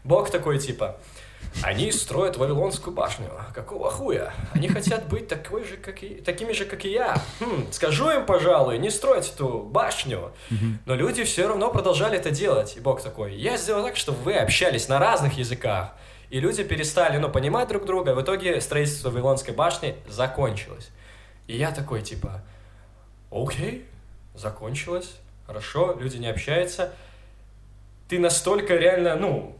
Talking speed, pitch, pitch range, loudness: 150 wpm, 130 Hz, 105-175 Hz, -24 LUFS